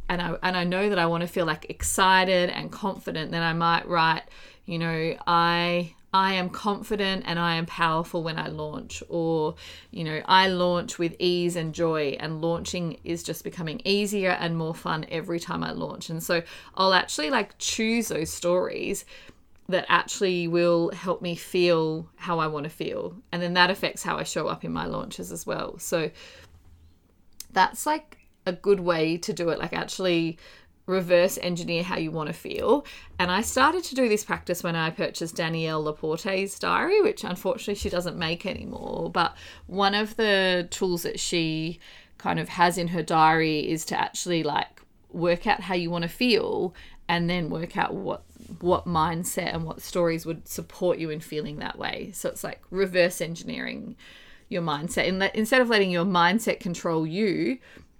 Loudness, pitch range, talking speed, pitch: -26 LUFS, 165-190 Hz, 185 wpm, 175 Hz